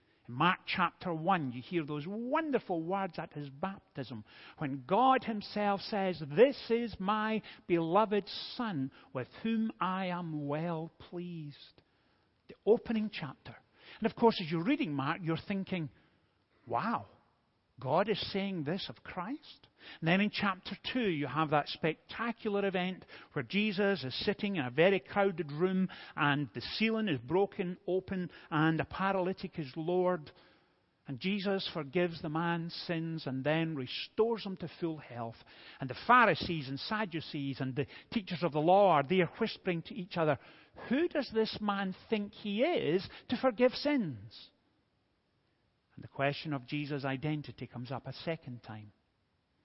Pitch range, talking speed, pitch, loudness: 150-205 Hz, 150 wpm, 175 Hz, -33 LUFS